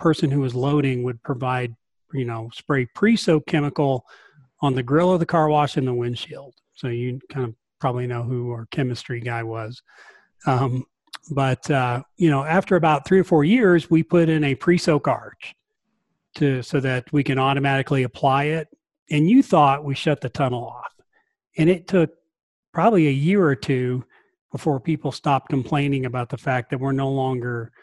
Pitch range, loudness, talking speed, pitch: 130-165 Hz, -21 LUFS, 180 wpm, 140 Hz